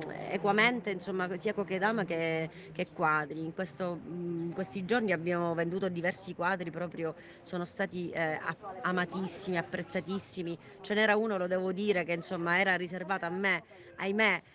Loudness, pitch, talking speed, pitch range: -32 LUFS, 180 Hz, 145 wpm, 170-195 Hz